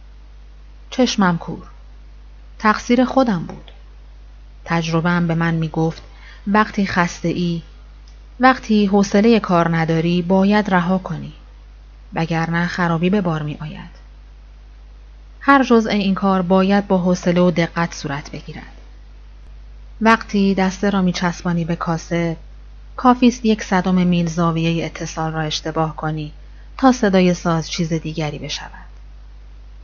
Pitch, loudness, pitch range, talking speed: 170 Hz, -18 LUFS, 155-190 Hz, 120 wpm